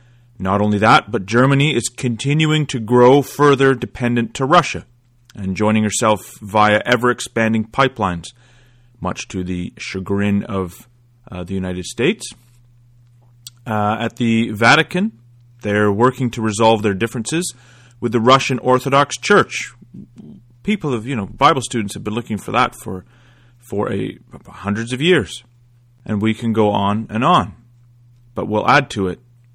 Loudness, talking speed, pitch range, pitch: -17 LUFS, 145 wpm, 105-125 Hz, 120 Hz